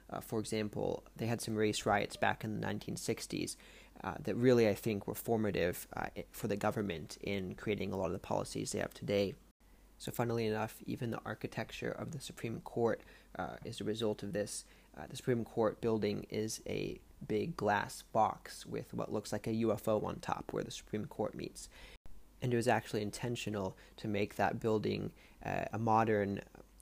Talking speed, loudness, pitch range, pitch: 190 wpm, -37 LUFS, 105-115 Hz, 110 Hz